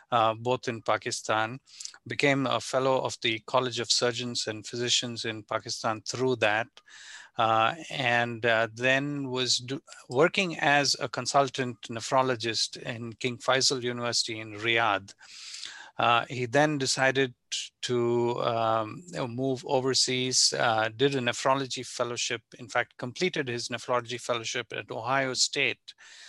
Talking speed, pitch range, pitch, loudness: 130 wpm, 115-130 Hz, 125 Hz, -27 LUFS